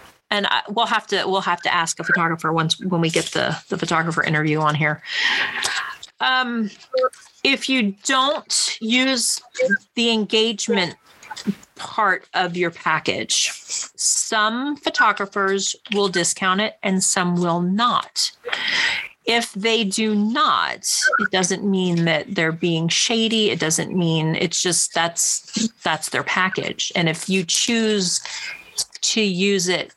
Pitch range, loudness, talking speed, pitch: 175-225 Hz, -20 LUFS, 135 wpm, 195 Hz